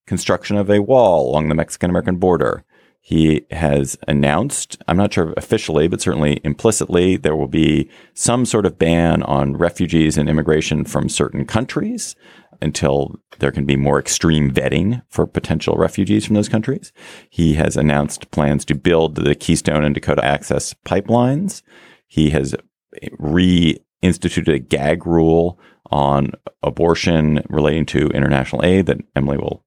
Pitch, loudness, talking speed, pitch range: 80 Hz, -17 LUFS, 150 wpm, 75-90 Hz